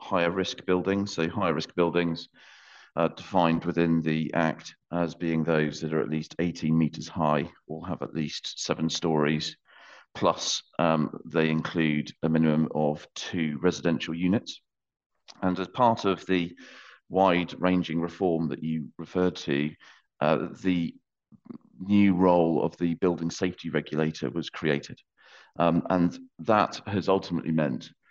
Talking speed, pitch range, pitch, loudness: 145 wpm, 80-90 Hz, 85 Hz, -27 LUFS